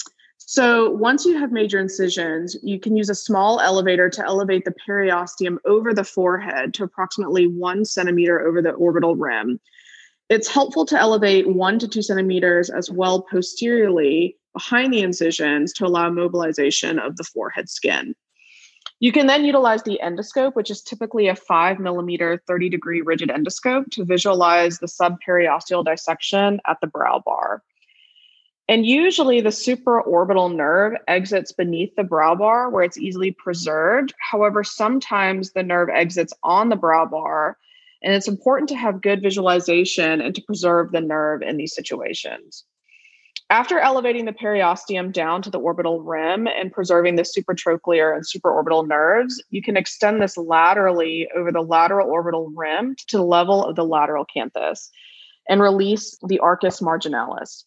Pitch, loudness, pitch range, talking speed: 190 Hz, -19 LUFS, 170-220 Hz, 155 wpm